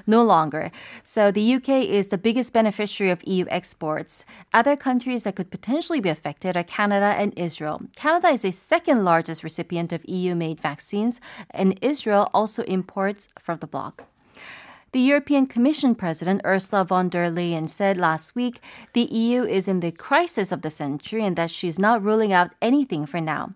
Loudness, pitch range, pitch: -22 LUFS, 170-235 Hz, 195 Hz